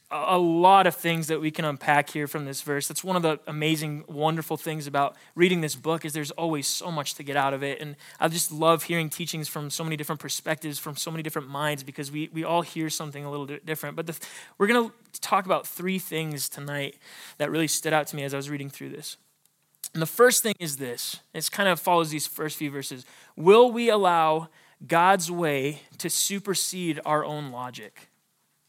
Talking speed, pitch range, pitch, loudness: 220 wpm, 145-165 Hz, 155 Hz, -26 LUFS